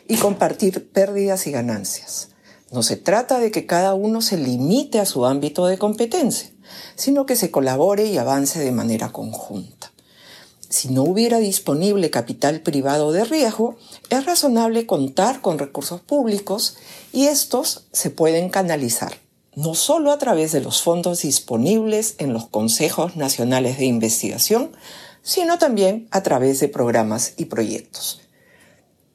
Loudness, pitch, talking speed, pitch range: -19 LUFS, 185 Hz, 140 wpm, 140-225 Hz